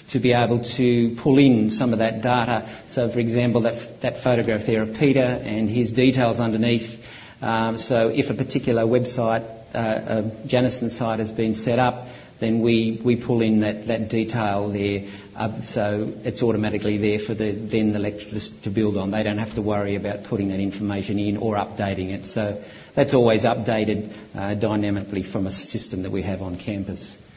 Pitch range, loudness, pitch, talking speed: 105-120 Hz, -22 LUFS, 110 Hz, 190 wpm